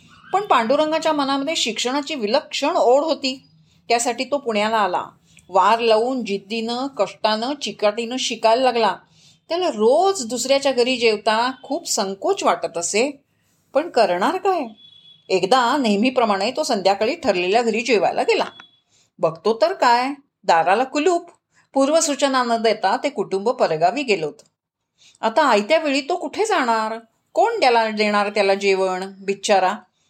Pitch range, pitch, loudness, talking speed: 210-290 Hz, 240 Hz, -19 LUFS, 125 wpm